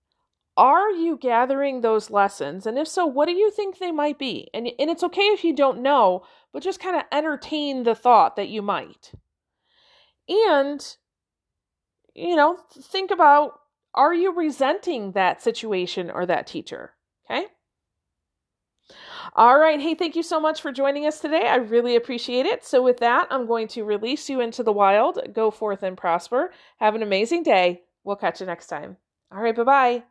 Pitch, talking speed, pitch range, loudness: 260 Hz, 180 wpm, 215-315 Hz, -21 LUFS